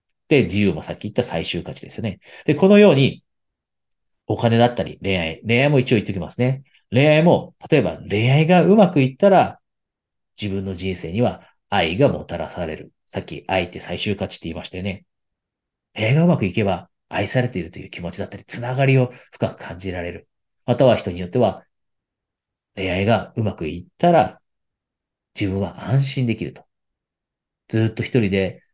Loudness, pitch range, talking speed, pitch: -20 LUFS, 95-125 Hz, 345 characters per minute, 105 Hz